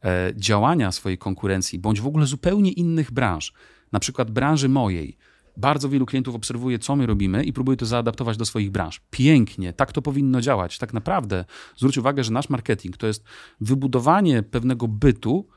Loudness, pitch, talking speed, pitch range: -22 LUFS, 125 Hz, 170 wpm, 105-135 Hz